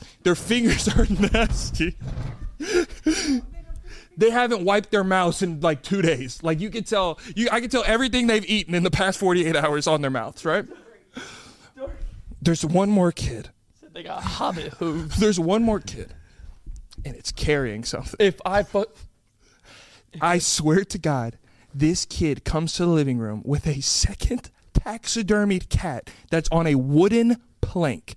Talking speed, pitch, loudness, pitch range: 145 wpm, 175 Hz, -23 LUFS, 150-210 Hz